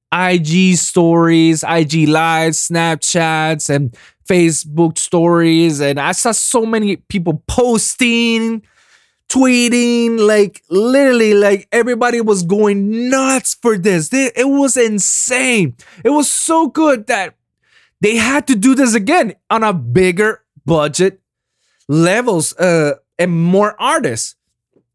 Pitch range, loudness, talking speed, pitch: 165-240 Hz, -13 LUFS, 120 wpm, 205 Hz